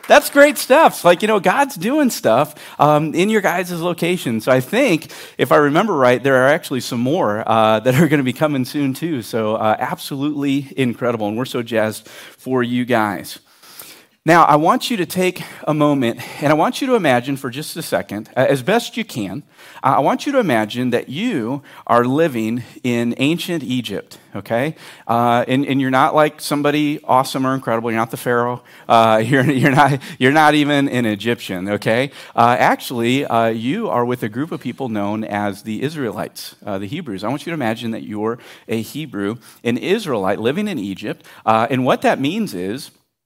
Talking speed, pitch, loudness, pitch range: 200 wpm, 130 Hz, -17 LUFS, 115-155 Hz